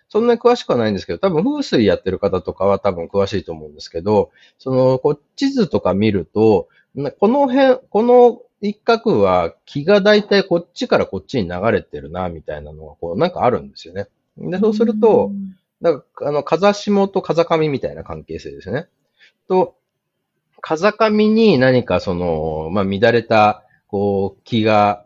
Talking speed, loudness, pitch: 320 characters per minute, -17 LUFS, 145 Hz